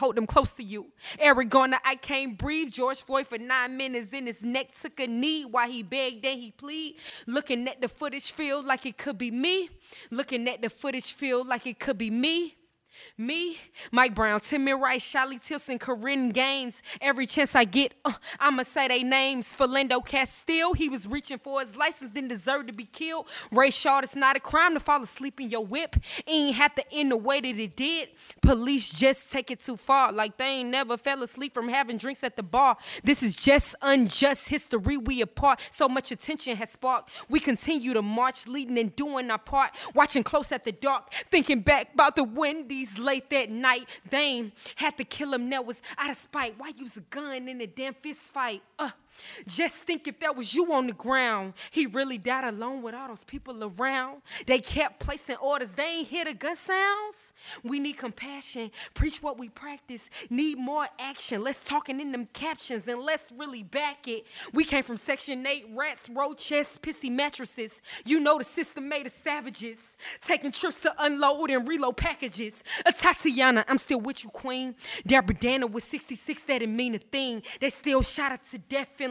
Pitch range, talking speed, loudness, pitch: 250-285 Hz, 205 wpm, -26 LUFS, 270 Hz